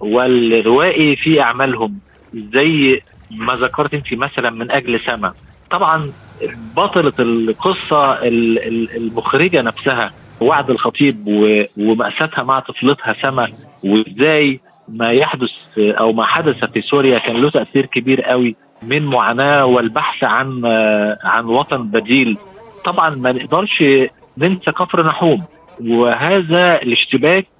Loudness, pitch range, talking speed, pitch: -14 LUFS, 115-145 Hz, 110 wpm, 125 Hz